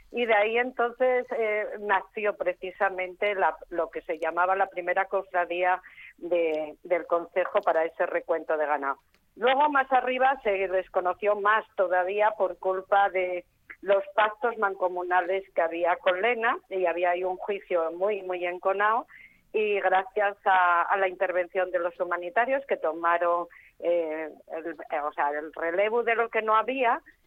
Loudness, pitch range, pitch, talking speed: -27 LUFS, 175-210 Hz, 190 Hz, 150 wpm